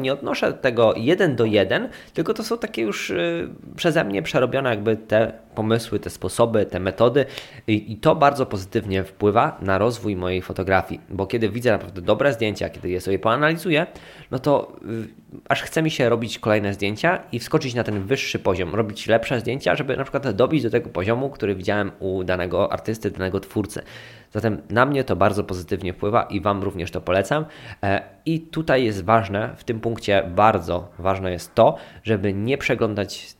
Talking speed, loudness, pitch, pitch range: 180 wpm, -22 LUFS, 110 Hz, 95-125 Hz